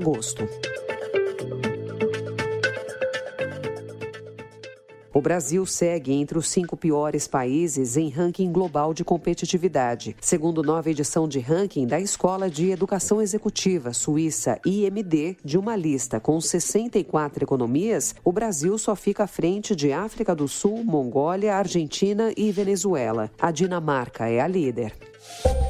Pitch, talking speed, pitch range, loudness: 170 Hz, 115 wpm, 135-195 Hz, -24 LUFS